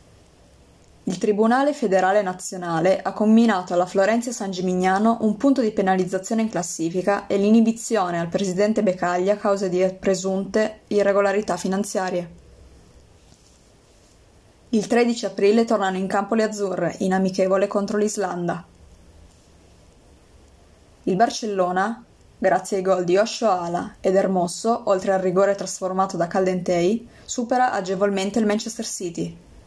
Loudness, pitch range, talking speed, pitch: -21 LUFS, 175-210 Hz, 120 wpm, 190 Hz